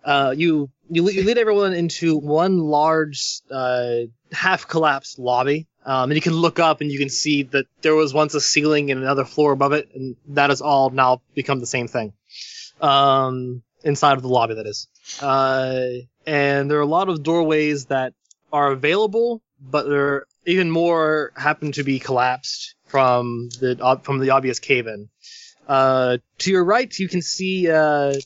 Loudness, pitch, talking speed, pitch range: -19 LUFS, 140 Hz, 180 wpm, 130-155 Hz